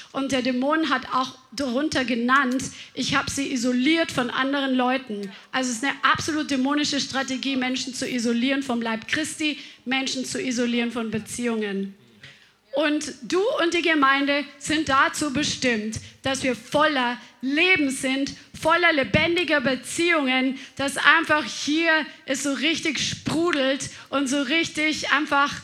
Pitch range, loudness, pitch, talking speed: 255-300 Hz, -23 LUFS, 270 Hz, 140 wpm